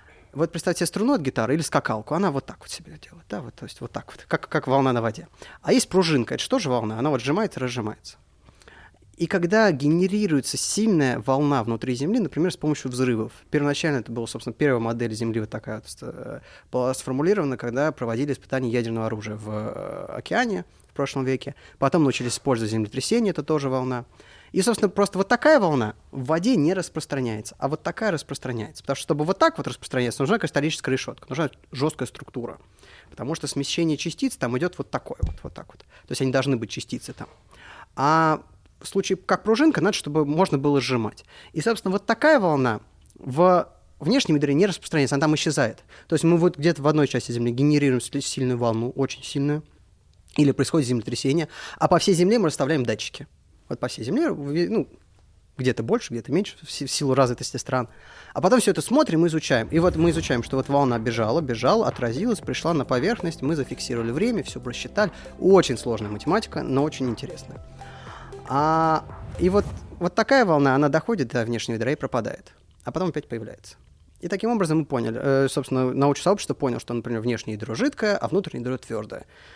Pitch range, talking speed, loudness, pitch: 125-170 Hz, 190 wpm, -23 LUFS, 140 Hz